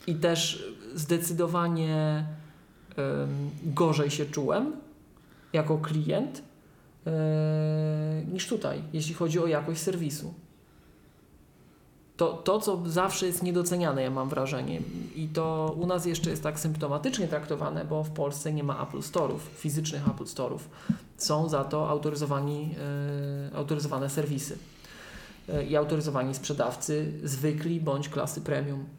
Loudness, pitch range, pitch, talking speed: -30 LUFS, 145-165 Hz, 155 Hz, 125 wpm